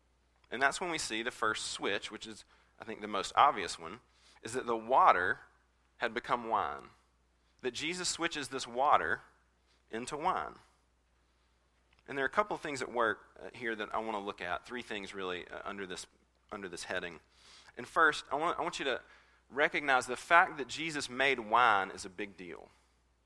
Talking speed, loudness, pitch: 190 wpm, -33 LUFS, 100 Hz